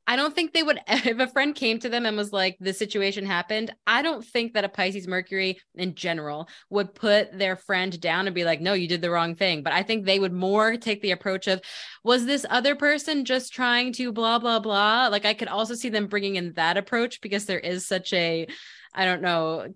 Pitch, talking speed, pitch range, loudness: 205 Hz, 235 wpm, 185-235 Hz, -24 LUFS